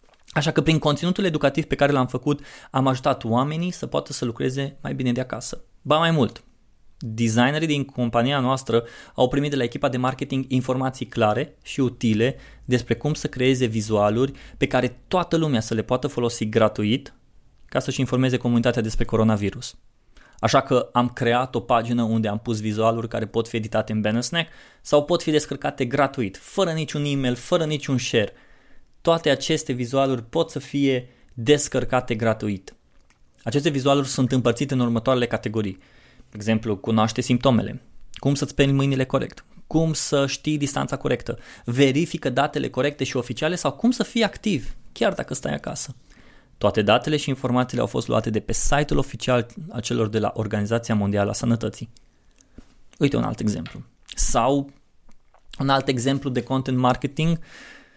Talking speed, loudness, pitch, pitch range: 165 wpm, -23 LUFS, 130 Hz, 115-145 Hz